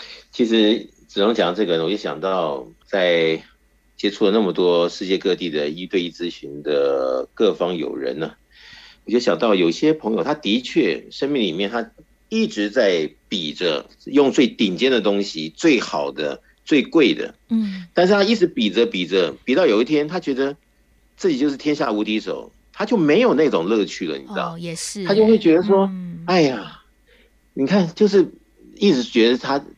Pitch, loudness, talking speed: 150 Hz, -19 LUFS, 255 characters per minute